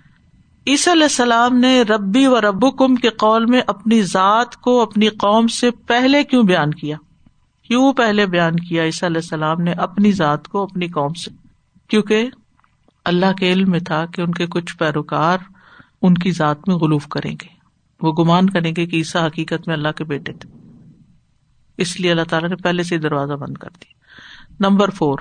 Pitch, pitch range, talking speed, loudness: 185 Hz, 165-225 Hz, 185 wpm, -16 LUFS